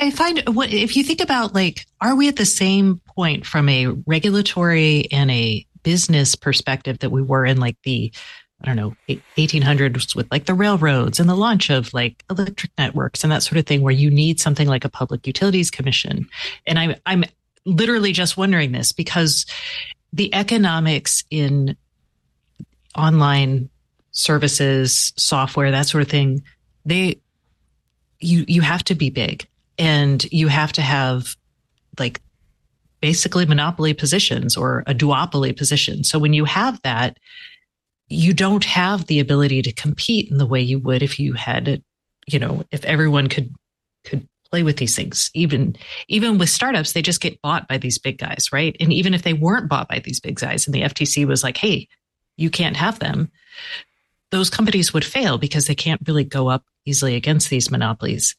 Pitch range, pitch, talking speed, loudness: 140-180 Hz, 155 Hz, 175 wpm, -18 LUFS